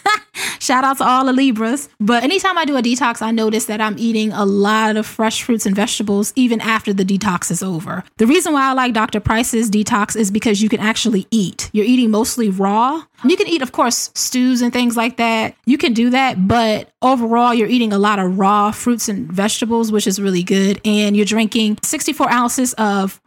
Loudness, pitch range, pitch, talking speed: -16 LUFS, 210-245 Hz, 225 Hz, 215 wpm